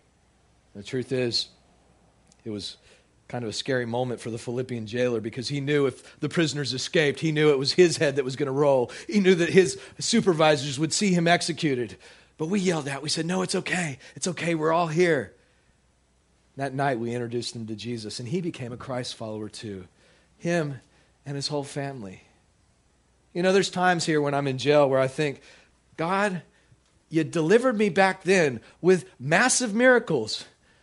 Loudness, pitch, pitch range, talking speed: -25 LUFS, 145 Hz, 120-170 Hz, 185 wpm